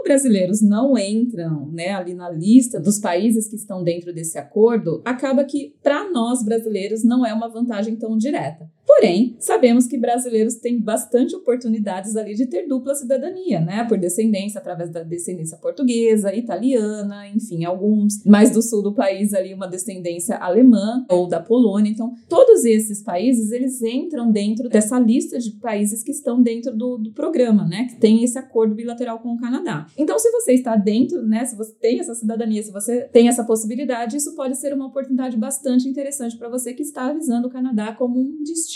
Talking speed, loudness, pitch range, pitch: 185 wpm, -19 LUFS, 210-255 Hz, 230 Hz